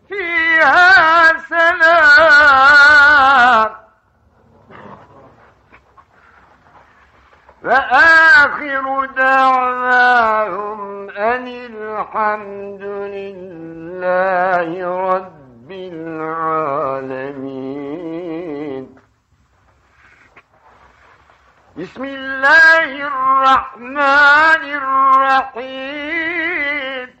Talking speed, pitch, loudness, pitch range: 30 wpm, 250 Hz, -11 LUFS, 185-290 Hz